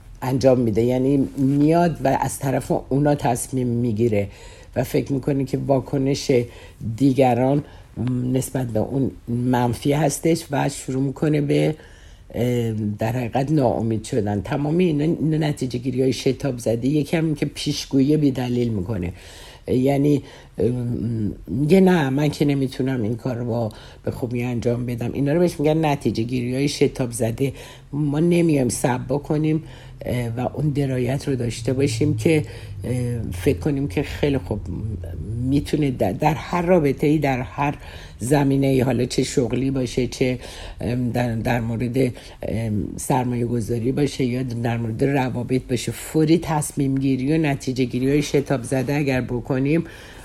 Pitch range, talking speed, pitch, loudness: 120-145 Hz, 140 wpm, 130 Hz, -22 LUFS